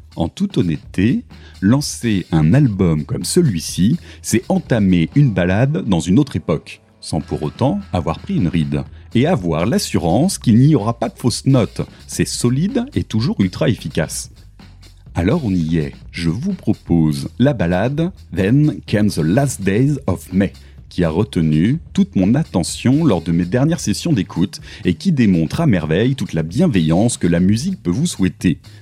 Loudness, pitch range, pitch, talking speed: -17 LUFS, 85-130 Hz, 100 Hz, 170 wpm